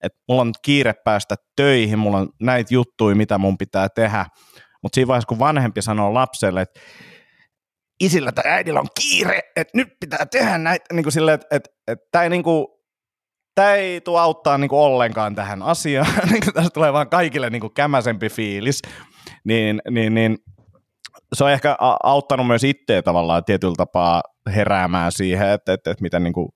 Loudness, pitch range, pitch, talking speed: -18 LUFS, 100-145 Hz, 120 Hz, 175 wpm